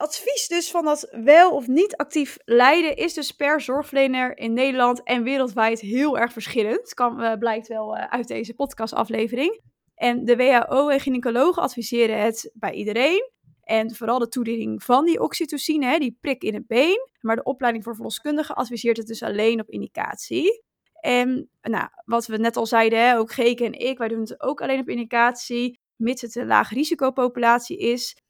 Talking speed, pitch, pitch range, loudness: 180 wpm, 245 Hz, 230-290 Hz, -22 LUFS